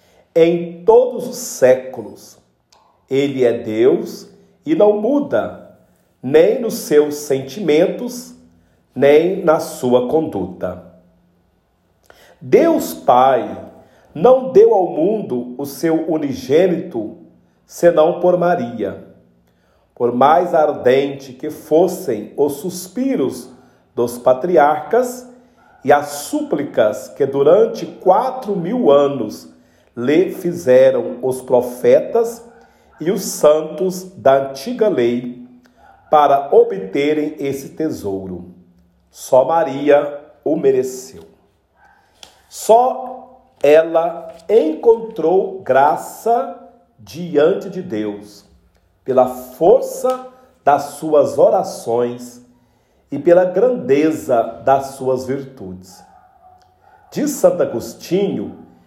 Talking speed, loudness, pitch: 90 wpm, -16 LUFS, 150 Hz